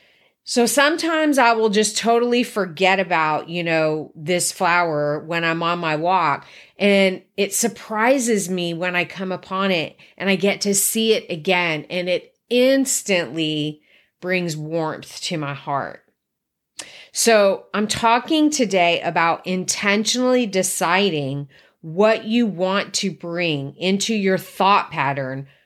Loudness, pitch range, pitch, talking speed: -19 LUFS, 170-220 Hz, 185 Hz, 135 wpm